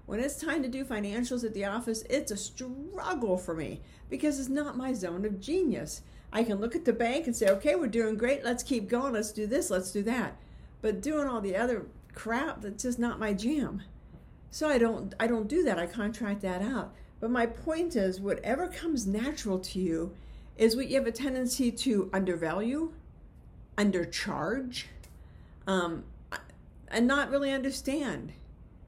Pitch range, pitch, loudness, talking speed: 205-270 Hz, 235 Hz, -31 LUFS, 175 wpm